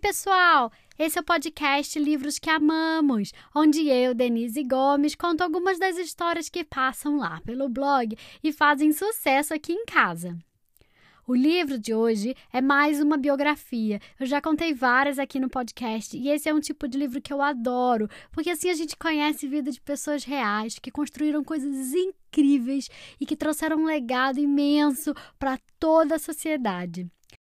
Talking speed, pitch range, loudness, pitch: 165 wpm, 260-315 Hz, -25 LUFS, 290 Hz